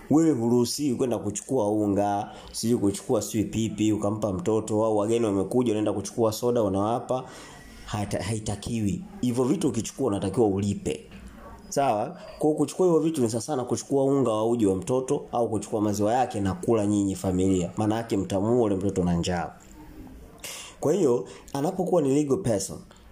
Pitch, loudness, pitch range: 110 Hz, -26 LUFS, 100-125 Hz